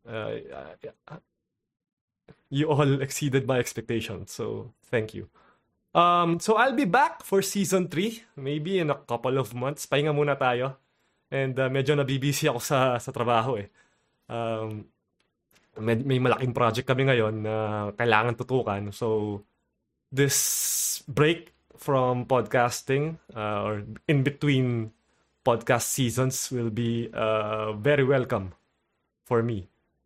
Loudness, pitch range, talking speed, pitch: -26 LUFS, 115-140 Hz, 125 wpm, 130 Hz